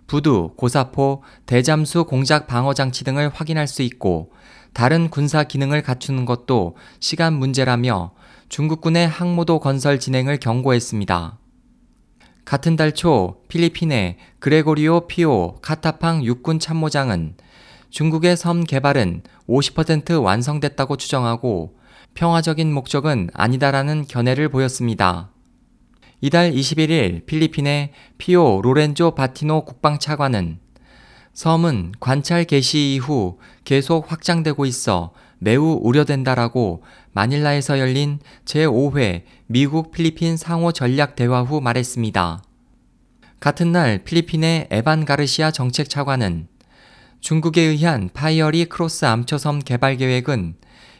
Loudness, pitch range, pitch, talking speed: -19 LUFS, 125-160 Hz, 145 Hz, 265 characters per minute